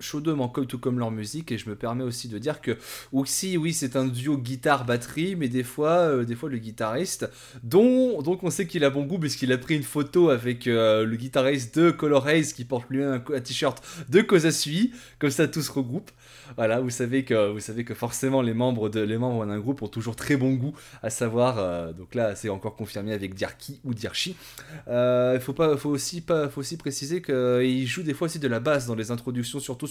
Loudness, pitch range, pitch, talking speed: -26 LUFS, 120-150 Hz, 130 Hz, 225 wpm